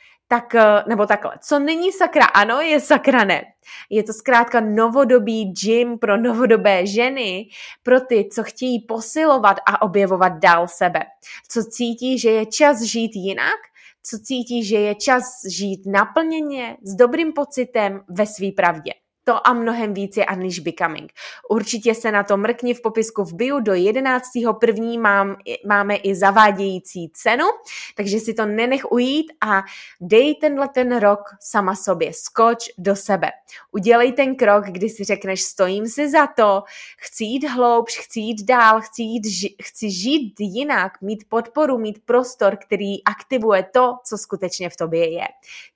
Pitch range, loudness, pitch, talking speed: 200-250 Hz, -18 LUFS, 225 Hz, 155 wpm